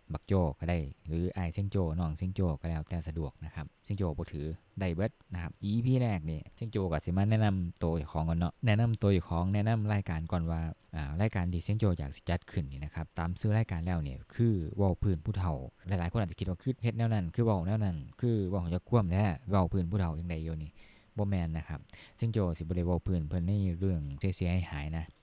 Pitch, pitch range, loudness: 90 Hz, 80-100 Hz, -33 LUFS